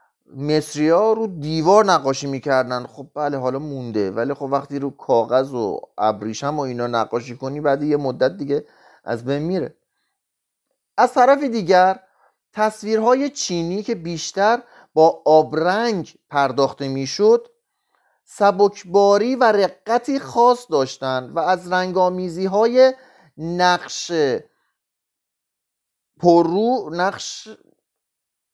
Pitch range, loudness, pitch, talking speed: 140-220 Hz, -19 LUFS, 175 Hz, 105 wpm